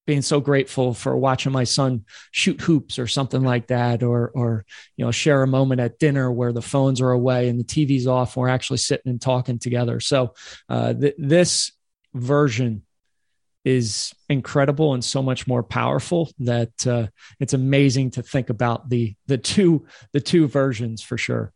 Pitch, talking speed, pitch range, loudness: 130 Hz, 180 wpm, 120-140 Hz, -21 LUFS